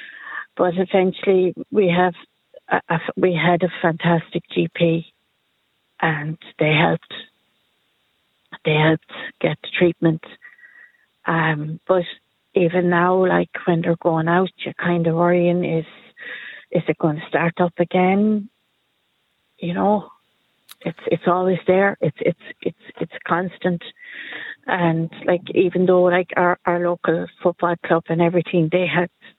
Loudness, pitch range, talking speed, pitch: -20 LUFS, 165-180 Hz, 135 wpm, 175 Hz